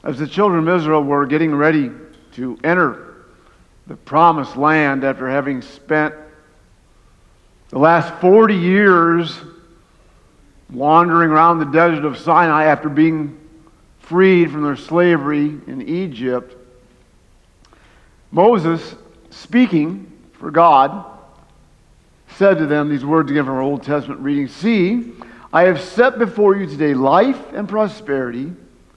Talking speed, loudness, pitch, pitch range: 120 wpm, -15 LUFS, 155 Hz, 145-175 Hz